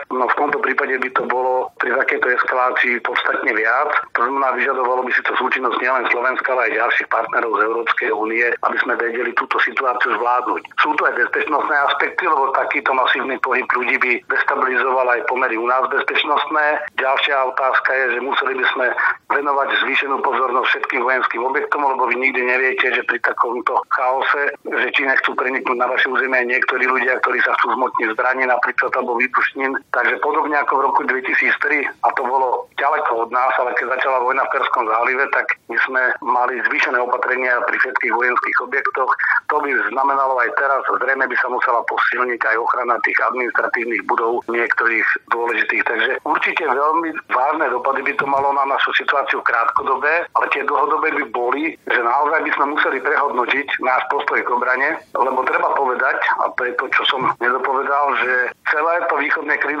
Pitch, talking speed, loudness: 150 Hz, 180 wpm, -17 LUFS